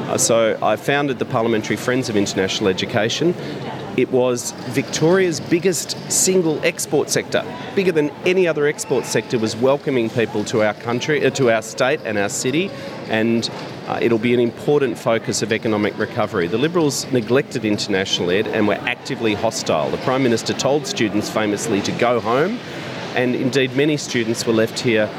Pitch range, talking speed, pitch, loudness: 110-145 Hz, 165 wpm, 125 Hz, -19 LUFS